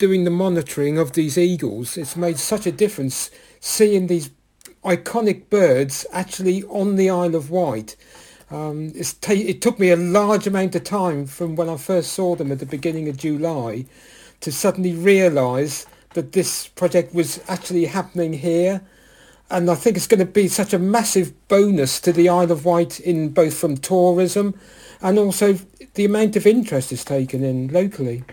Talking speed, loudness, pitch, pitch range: 170 wpm, -19 LUFS, 175 Hz, 160-195 Hz